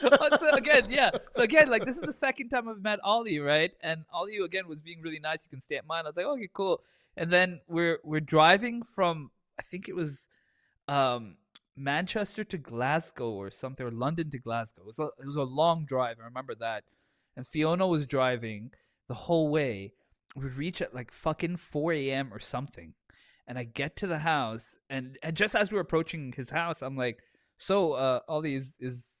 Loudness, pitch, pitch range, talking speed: -29 LUFS, 155 Hz, 130-180 Hz, 210 wpm